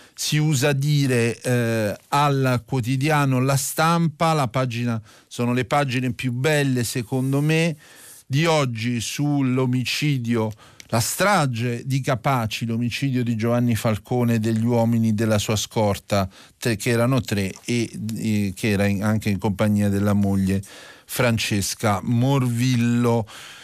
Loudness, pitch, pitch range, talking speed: -22 LUFS, 120 Hz, 110-135 Hz, 125 wpm